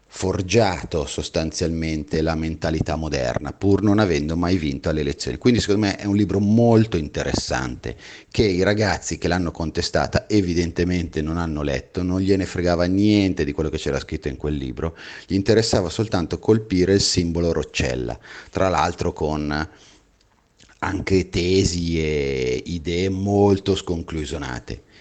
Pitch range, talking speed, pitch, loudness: 80-100 Hz, 140 wpm, 85 Hz, -21 LUFS